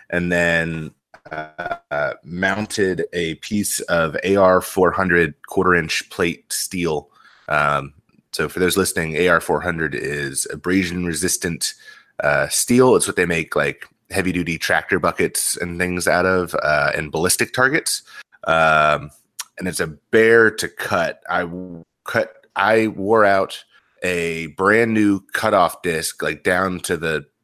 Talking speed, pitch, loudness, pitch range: 140 wpm, 90 Hz, -19 LUFS, 85-100 Hz